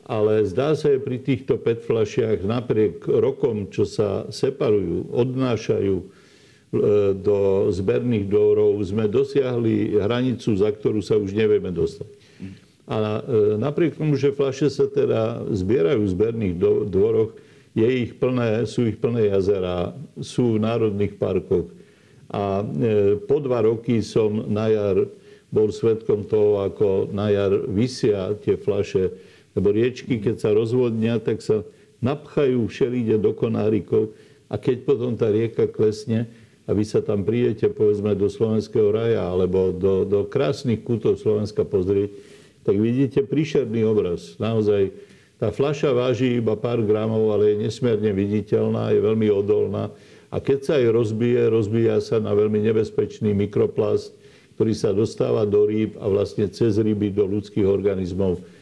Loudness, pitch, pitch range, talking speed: -22 LUFS, 110 Hz, 105-120 Hz, 140 wpm